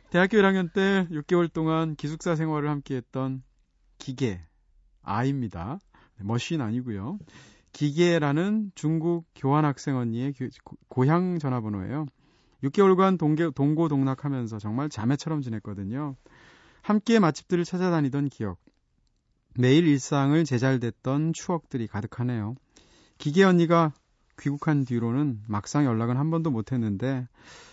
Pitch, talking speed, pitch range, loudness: 140 Hz, 280 characters per minute, 125-165 Hz, -26 LUFS